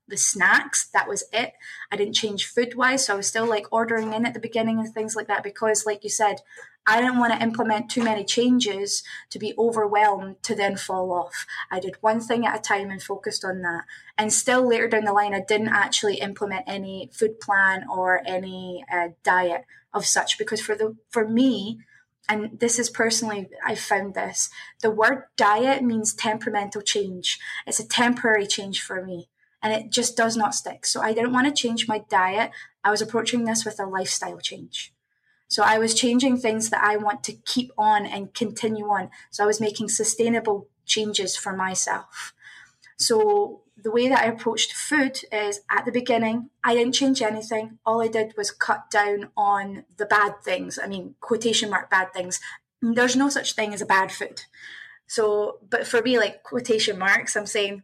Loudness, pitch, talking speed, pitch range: -23 LUFS, 215 Hz, 195 wpm, 200-230 Hz